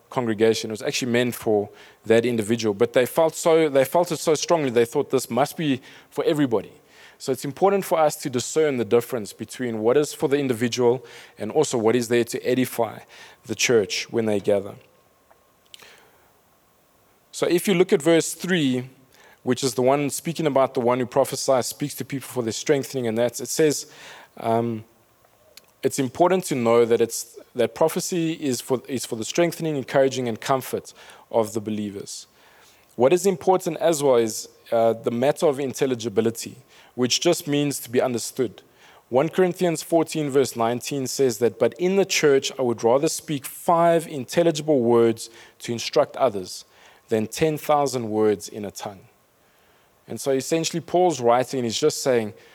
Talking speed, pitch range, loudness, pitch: 175 wpm, 120-155 Hz, -22 LUFS, 130 Hz